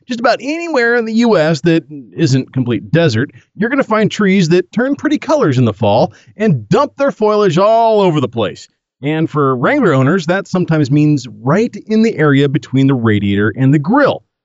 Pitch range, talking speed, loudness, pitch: 140-225 Hz, 195 wpm, -13 LUFS, 170 Hz